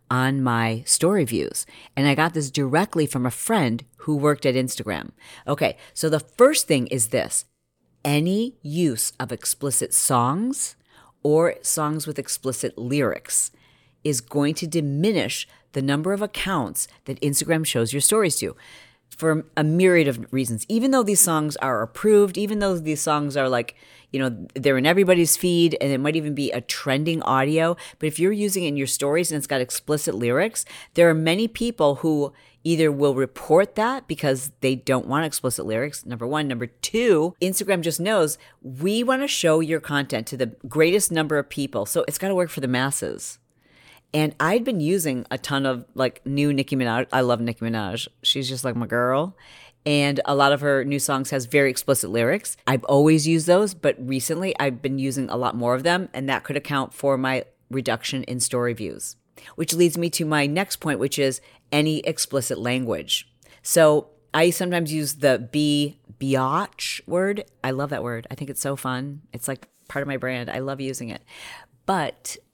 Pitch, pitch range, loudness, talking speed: 145 Hz, 130-165 Hz, -22 LUFS, 190 wpm